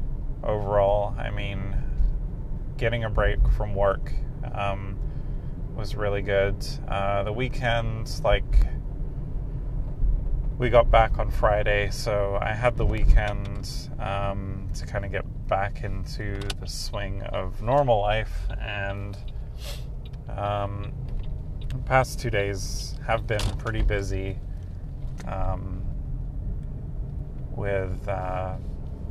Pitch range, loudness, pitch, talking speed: 100-115 Hz, -28 LUFS, 100 Hz, 105 wpm